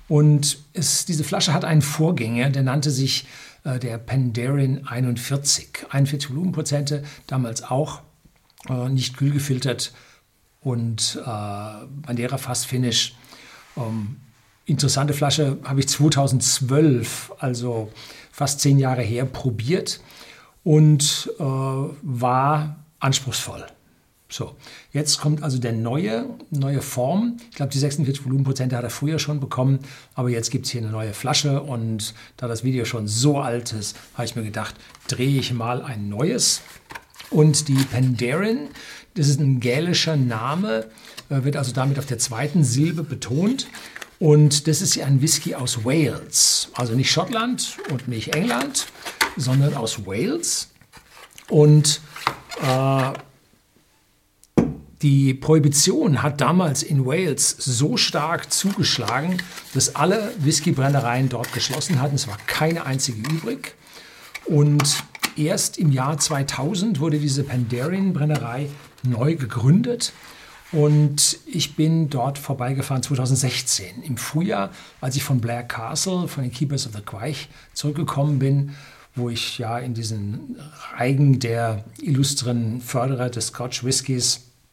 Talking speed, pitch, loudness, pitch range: 130 wpm, 135 Hz, -21 LUFS, 125-150 Hz